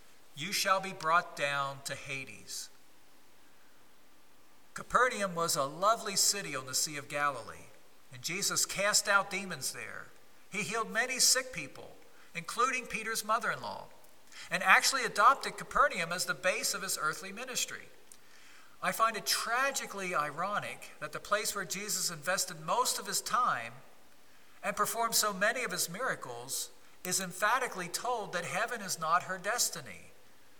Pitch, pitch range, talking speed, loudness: 195 Hz, 170-220 Hz, 145 wpm, -31 LUFS